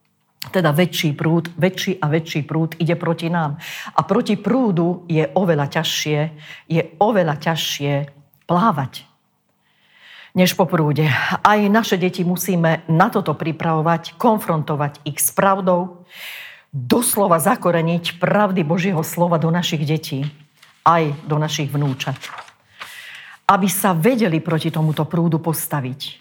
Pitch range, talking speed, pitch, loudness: 155-180 Hz, 120 wpm, 165 Hz, -19 LUFS